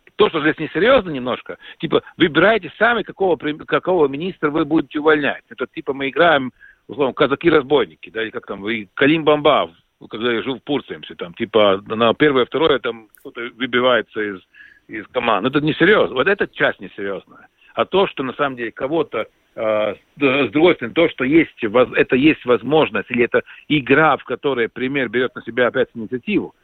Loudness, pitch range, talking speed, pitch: -18 LUFS, 115-155 Hz, 170 wpm, 140 Hz